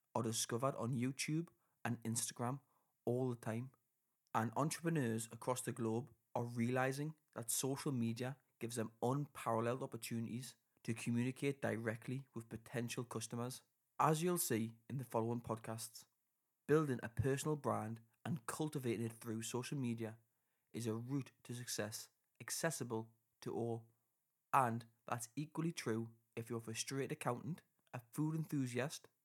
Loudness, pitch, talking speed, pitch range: -42 LUFS, 120 Hz, 135 wpm, 115-135 Hz